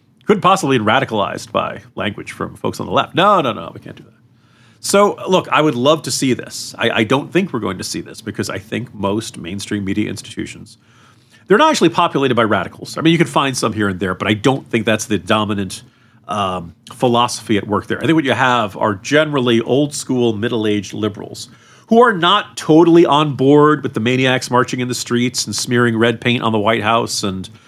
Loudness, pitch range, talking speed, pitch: -16 LUFS, 110-135 Hz, 225 wpm, 120 Hz